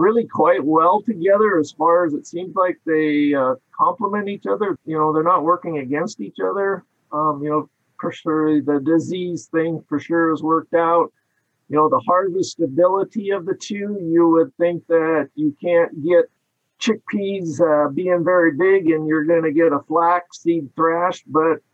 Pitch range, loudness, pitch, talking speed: 155-180 Hz, -19 LUFS, 165 Hz, 180 wpm